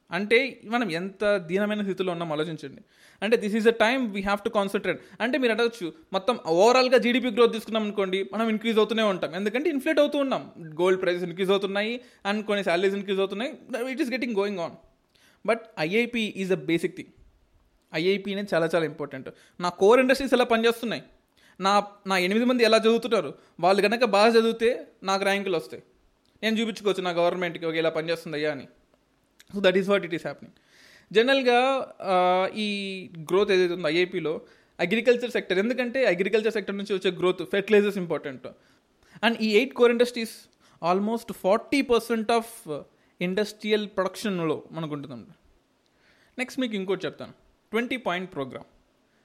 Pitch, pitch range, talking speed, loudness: 205 Hz, 180-230 Hz, 155 wpm, -25 LUFS